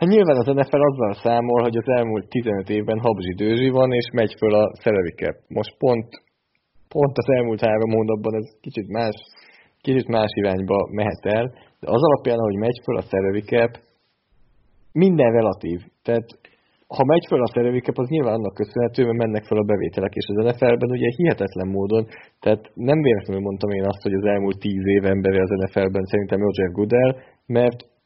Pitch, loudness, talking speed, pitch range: 110 Hz, -21 LUFS, 175 wpm, 100-120 Hz